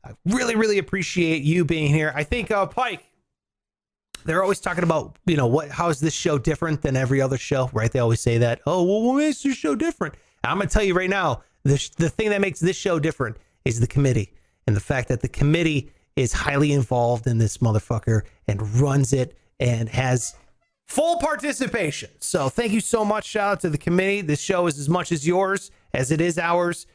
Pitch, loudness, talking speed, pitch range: 160 Hz, -22 LUFS, 220 wpm, 130-190 Hz